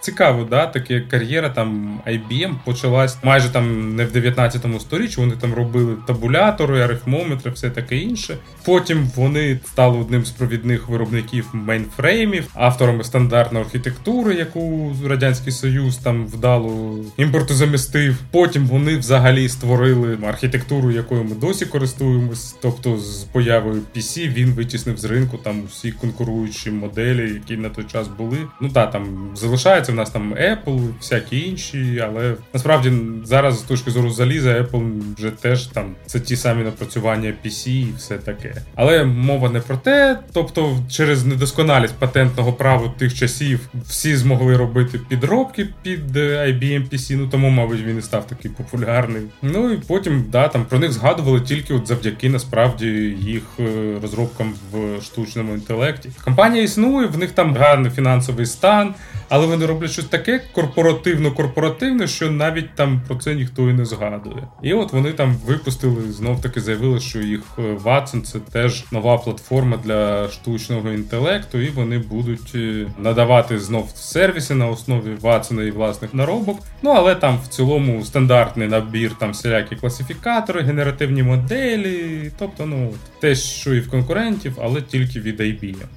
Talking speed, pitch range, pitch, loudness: 150 wpm, 115-140 Hz, 125 Hz, -18 LUFS